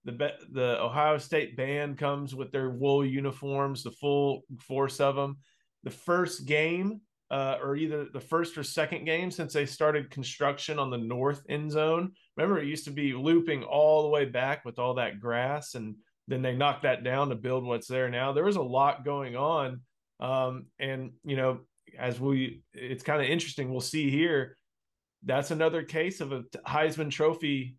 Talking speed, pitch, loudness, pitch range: 185 wpm, 140 Hz, -30 LUFS, 130-150 Hz